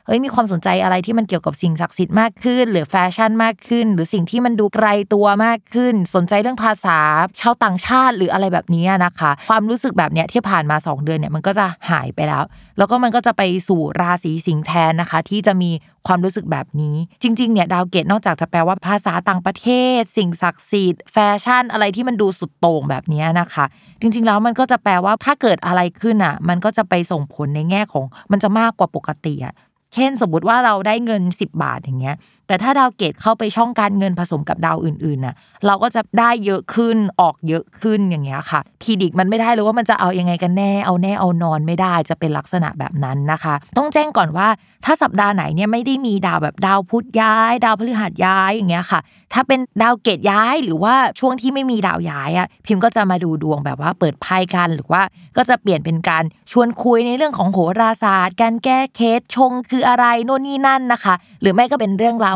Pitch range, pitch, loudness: 175-230 Hz, 195 Hz, -16 LUFS